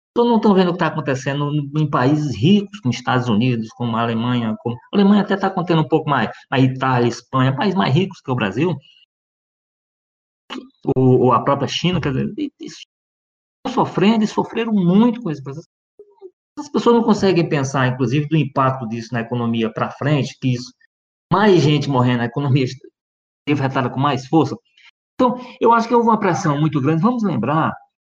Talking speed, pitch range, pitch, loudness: 180 wpm, 130-200 Hz, 150 Hz, -18 LUFS